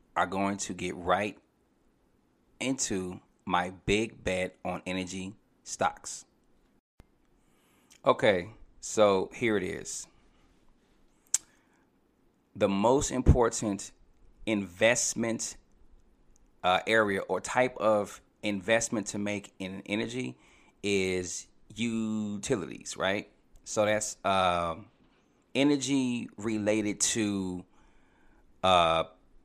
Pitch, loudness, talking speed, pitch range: 100 Hz, -30 LUFS, 85 wpm, 90-110 Hz